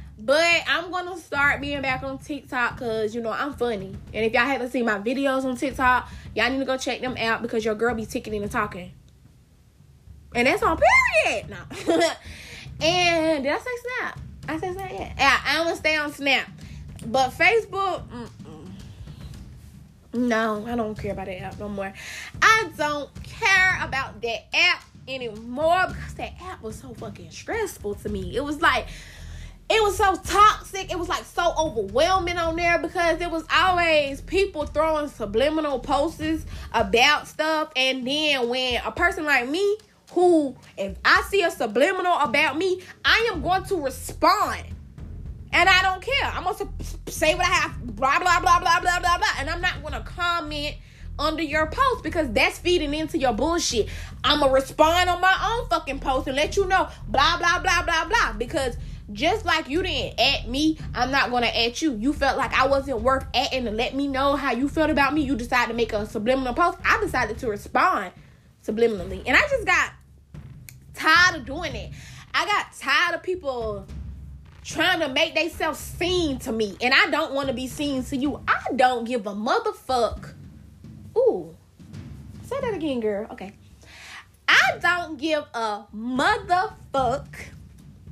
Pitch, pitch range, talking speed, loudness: 300 Hz, 255-350 Hz, 180 wpm, -22 LUFS